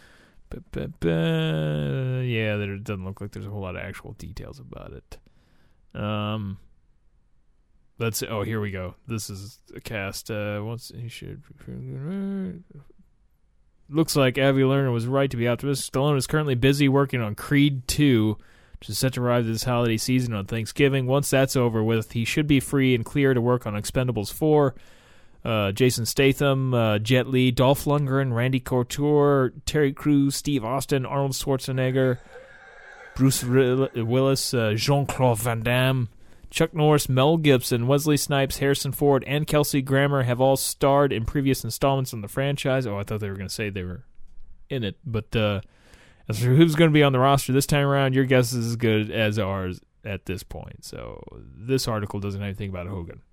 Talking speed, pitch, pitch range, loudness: 180 wpm, 125 Hz, 110-140 Hz, -23 LUFS